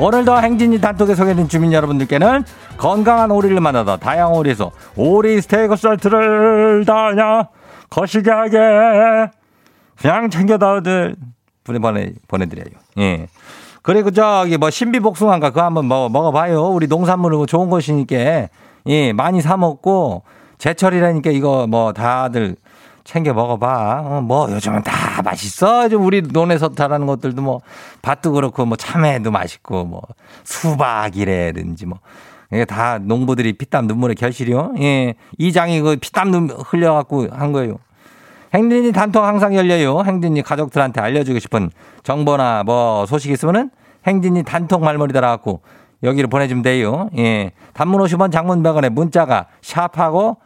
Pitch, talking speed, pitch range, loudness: 155 Hz, 320 characters per minute, 125-190 Hz, -15 LUFS